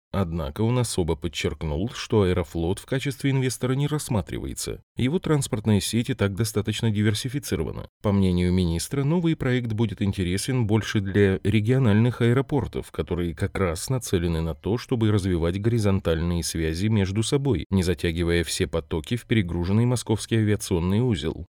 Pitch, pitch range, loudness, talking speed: 105 Hz, 90-120 Hz, -24 LUFS, 140 wpm